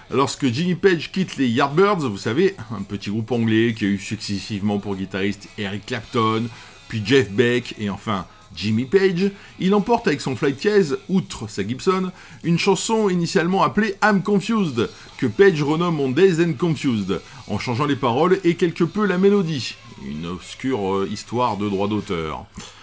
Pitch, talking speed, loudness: 135 Hz, 170 wpm, -21 LUFS